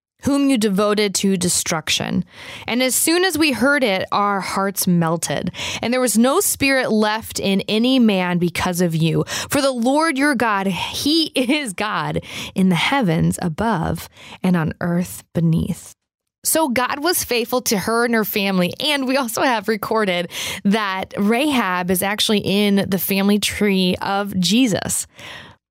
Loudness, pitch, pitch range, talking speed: -18 LUFS, 205 Hz, 185-250 Hz, 155 wpm